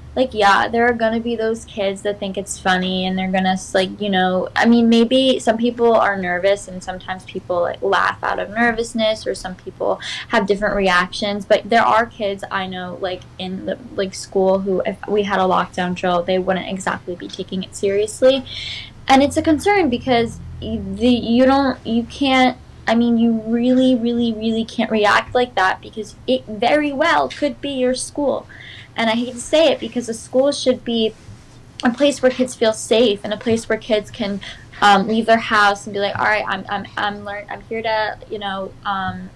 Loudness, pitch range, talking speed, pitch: -18 LUFS, 195-240 Hz, 205 wpm, 220 Hz